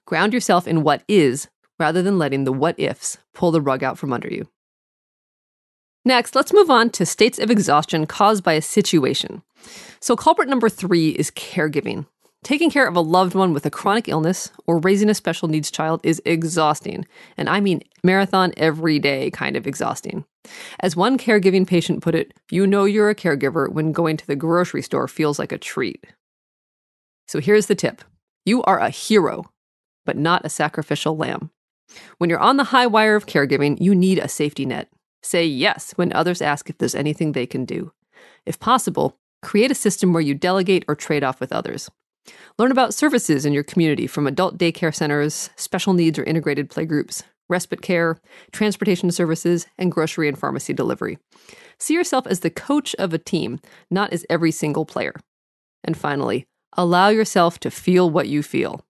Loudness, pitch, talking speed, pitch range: -19 LUFS, 175 Hz, 185 wpm, 155-200 Hz